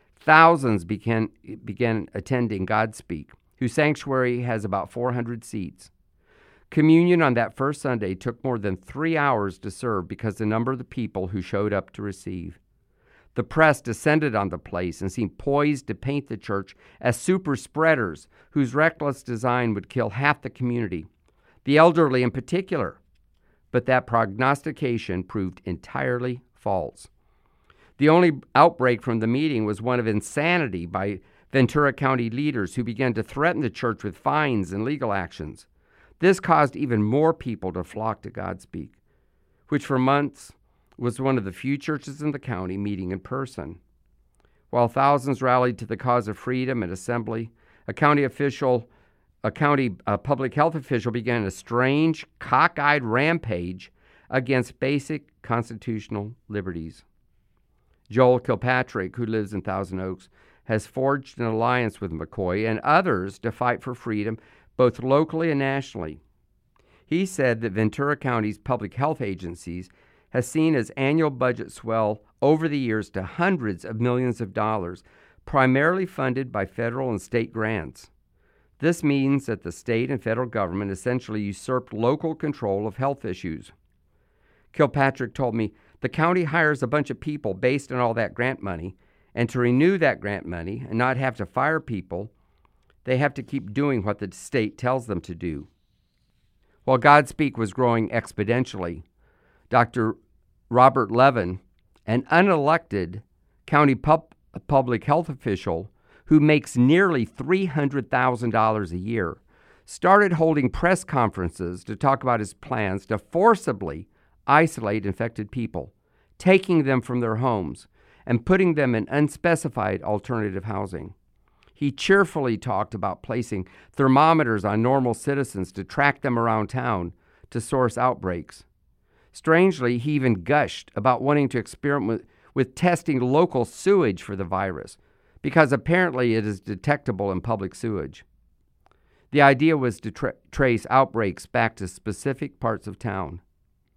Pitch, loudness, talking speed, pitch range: 120 Hz, -23 LUFS, 150 wpm, 100-140 Hz